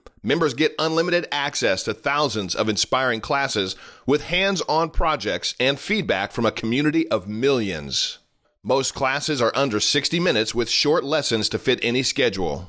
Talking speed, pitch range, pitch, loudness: 155 wpm, 110-155 Hz, 130 Hz, -21 LUFS